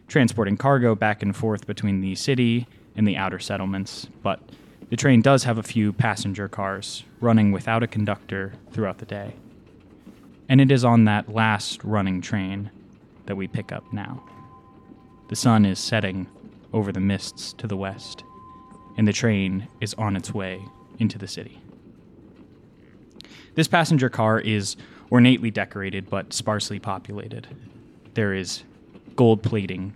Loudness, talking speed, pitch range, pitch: -23 LUFS, 150 wpm, 100-115 Hz, 105 Hz